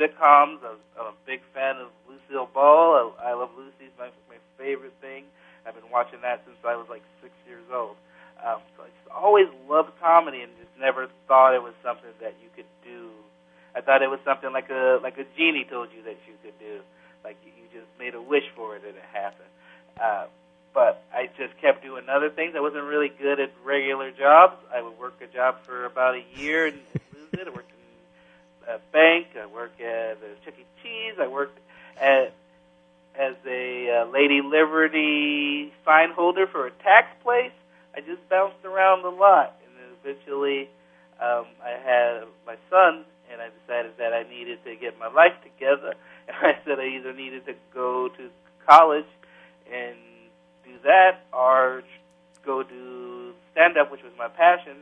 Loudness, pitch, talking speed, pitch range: -21 LUFS, 130 Hz, 195 wpm, 115-155 Hz